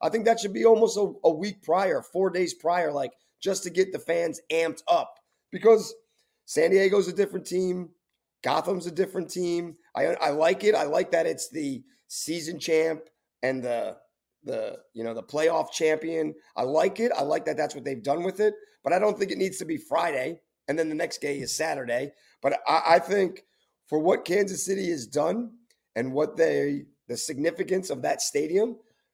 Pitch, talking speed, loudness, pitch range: 185 Hz, 200 wpm, -26 LUFS, 160-225 Hz